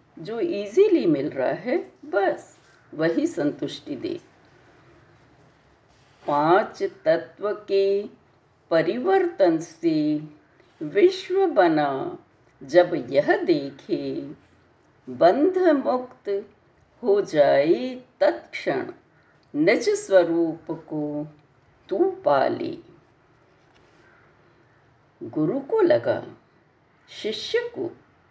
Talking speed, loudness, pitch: 70 wpm, -23 LUFS, 300 Hz